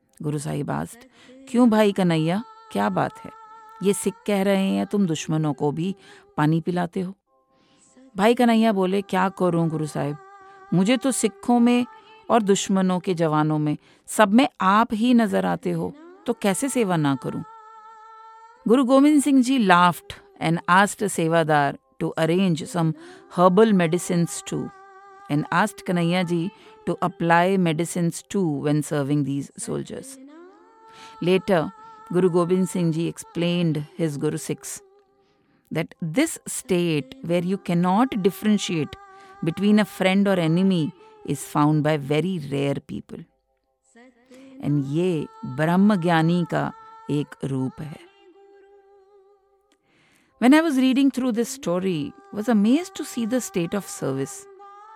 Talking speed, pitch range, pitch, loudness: 135 wpm, 165-265 Hz, 195 Hz, -22 LUFS